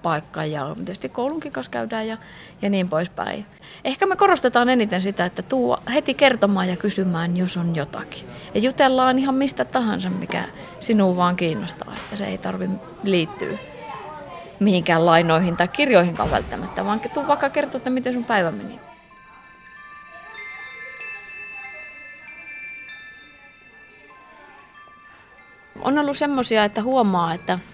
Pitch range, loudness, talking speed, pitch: 170-265 Hz, -21 LUFS, 125 wpm, 200 Hz